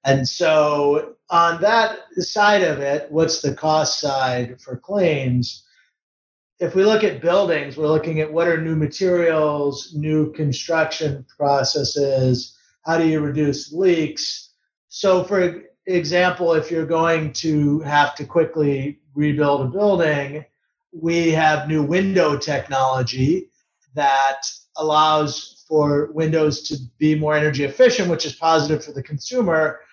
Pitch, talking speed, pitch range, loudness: 155 Hz, 130 wpm, 145-165 Hz, -19 LUFS